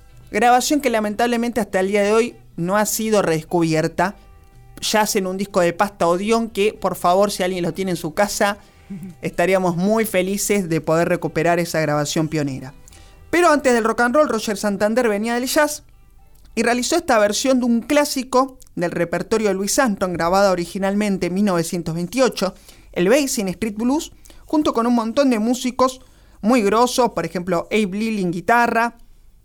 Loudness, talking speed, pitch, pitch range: -19 LUFS, 170 wpm, 205 Hz, 175-235 Hz